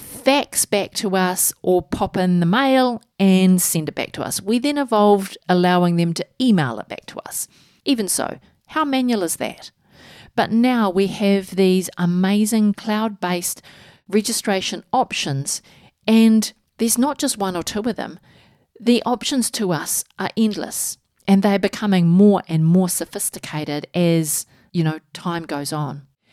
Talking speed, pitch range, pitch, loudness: 155 wpm, 175-225 Hz, 195 Hz, -19 LUFS